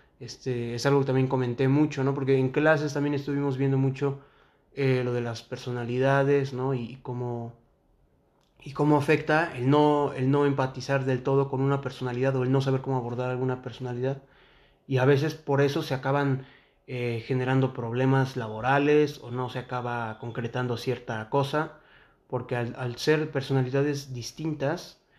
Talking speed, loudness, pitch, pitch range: 160 wpm, -27 LUFS, 135 Hz, 125-140 Hz